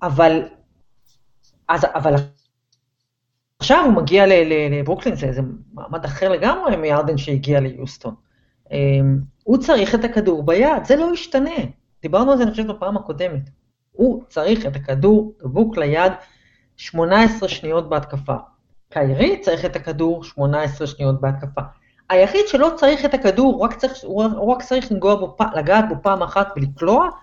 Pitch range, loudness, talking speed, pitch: 140-220 Hz, -18 LUFS, 135 wpm, 170 Hz